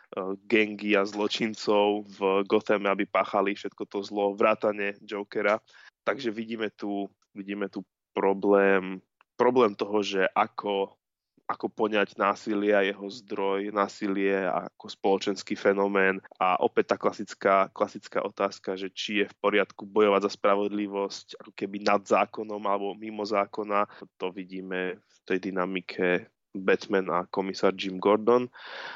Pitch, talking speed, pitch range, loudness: 100 Hz, 130 wpm, 95-105 Hz, -27 LUFS